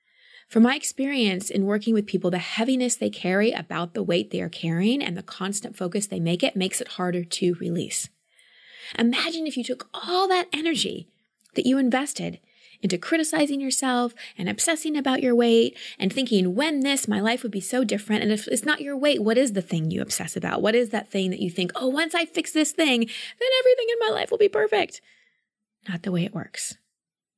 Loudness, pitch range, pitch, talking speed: -24 LUFS, 195-290 Hz, 235 Hz, 210 wpm